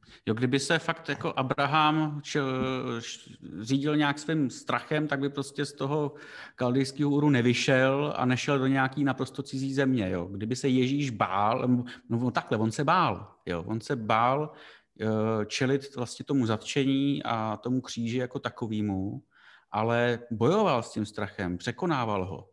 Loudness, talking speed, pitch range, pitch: -28 LUFS, 155 wpm, 115-140 Hz, 130 Hz